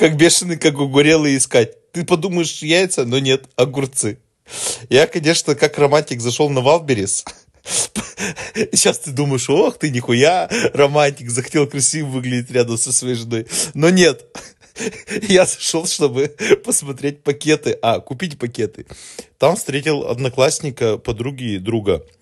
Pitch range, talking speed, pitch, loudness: 130-160 Hz, 130 wpm, 145 Hz, -17 LUFS